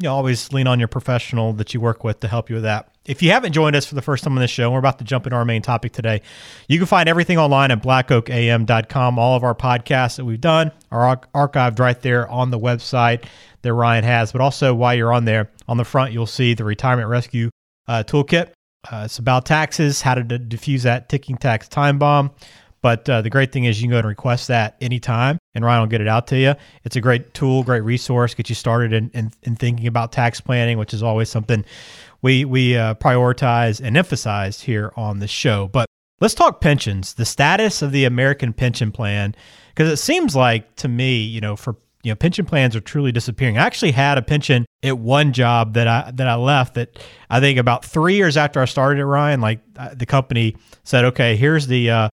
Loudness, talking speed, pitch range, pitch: -18 LUFS, 230 wpm, 115-135 Hz, 125 Hz